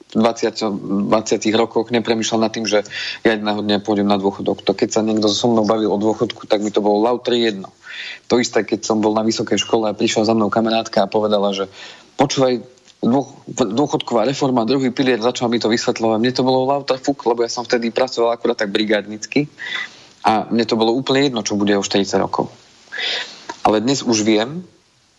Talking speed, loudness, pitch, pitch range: 195 wpm, -18 LUFS, 115 Hz, 105-125 Hz